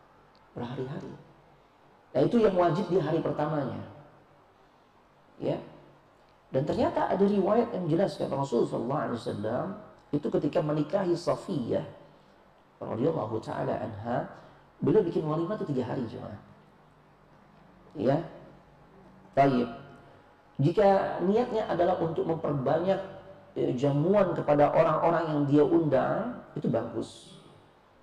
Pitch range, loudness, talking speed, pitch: 140-190 Hz, -28 LUFS, 100 wpm, 160 Hz